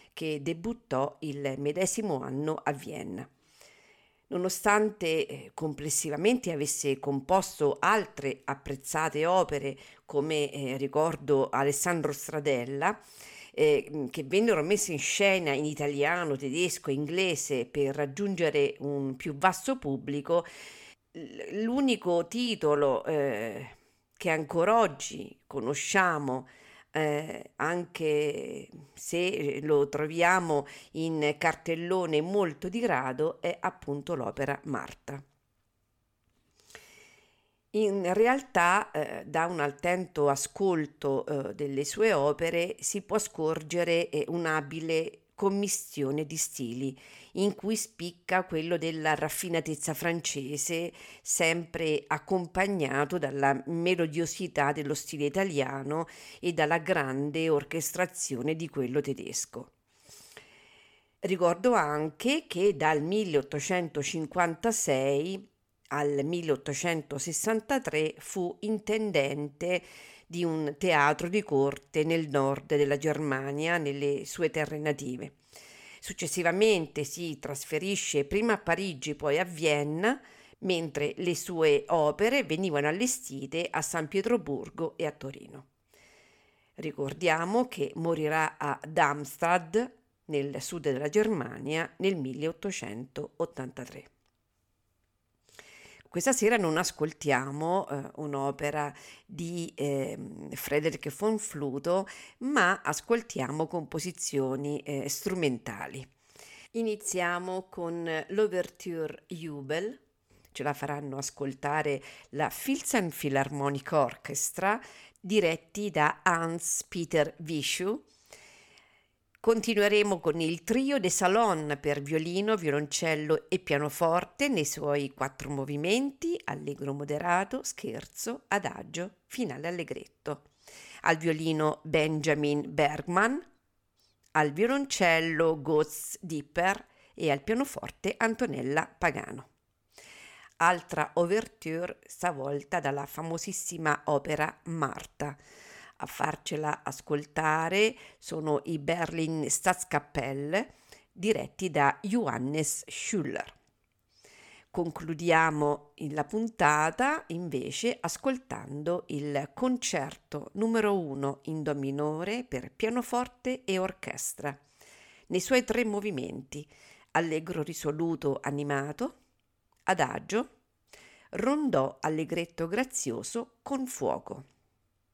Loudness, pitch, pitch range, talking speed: -30 LUFS, 160 Hz, 145-185 Hz, 90 wpm